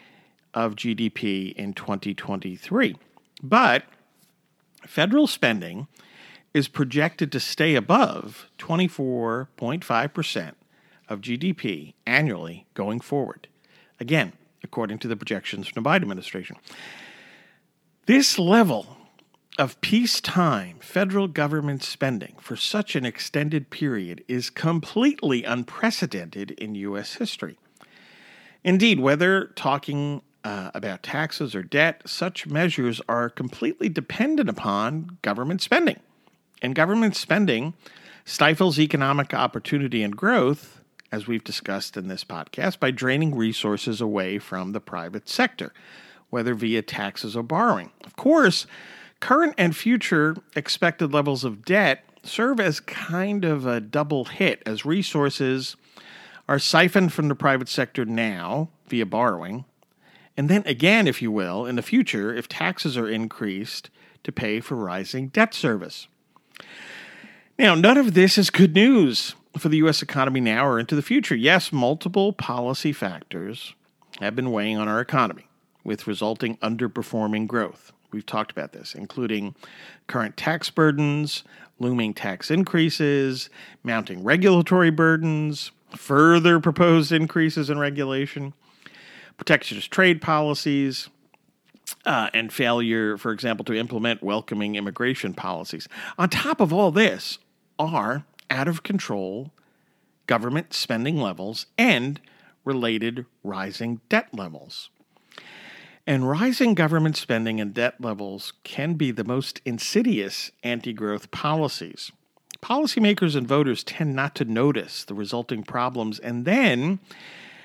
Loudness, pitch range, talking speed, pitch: -23 LUFS, 115-170 Hz, 120 wpm, 140 Hz